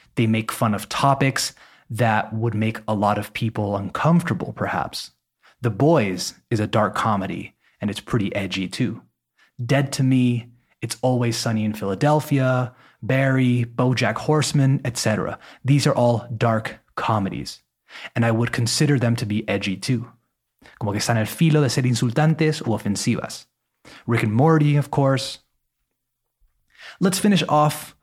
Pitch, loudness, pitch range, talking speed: 120 Hz, -21 LUFS, 110-135 Hz, 150 wpm